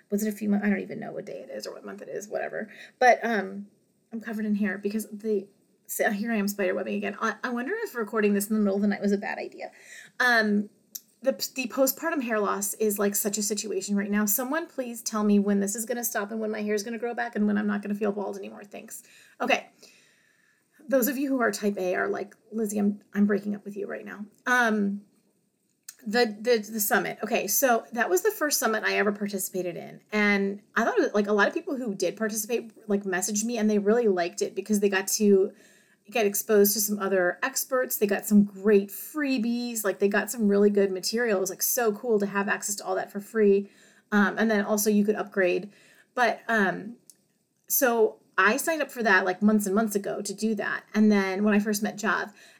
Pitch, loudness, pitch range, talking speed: 210 Hz, -26 LUFS, 200-230 Hz, 245 wpm